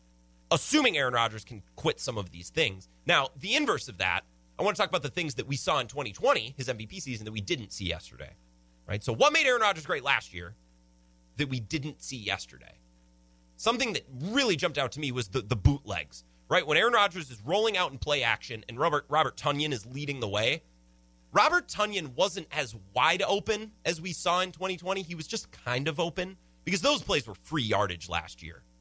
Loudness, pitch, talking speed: -29 LUFS, 125 Hz, 210 wpm